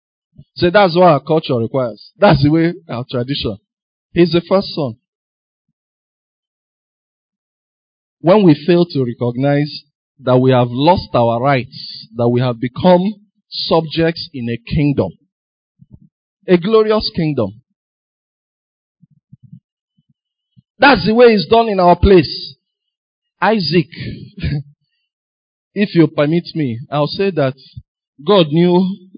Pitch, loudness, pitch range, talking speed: 160 Hz, -14 LUFS, 130-185 Hz, 115 wpm